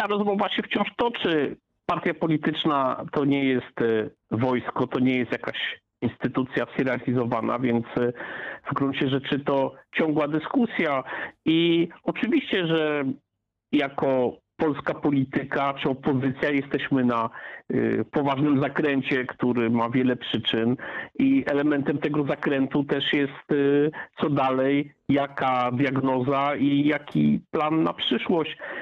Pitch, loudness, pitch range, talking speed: 140 Hz, -25 LUFS, 130-155 Hz, 120 wpm